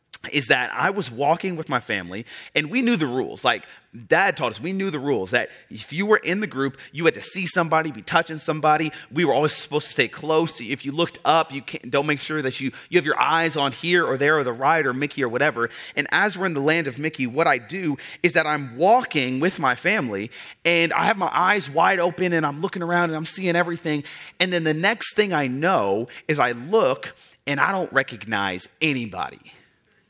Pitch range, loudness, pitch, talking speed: 140-175 Hz, -22 LUFS, 160 Hz, 245 wpm